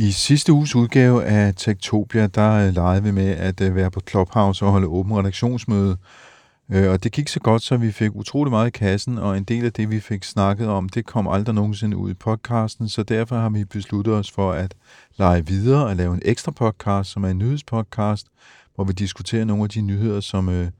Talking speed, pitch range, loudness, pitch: 220 wpm, 95-115 Hz, -20 LUFS, 105 Hz